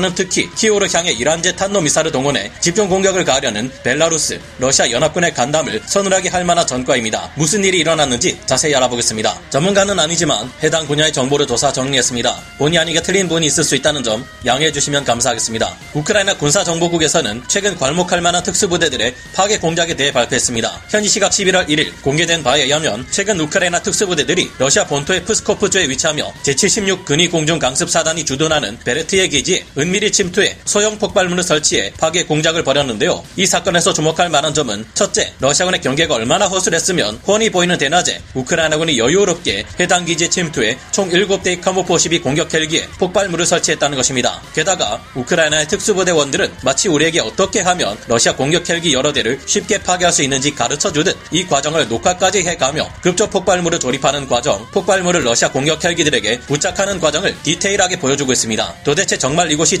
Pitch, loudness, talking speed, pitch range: 165 Hz, -14 LUFS, 455 characters per minute, 145-190 Hz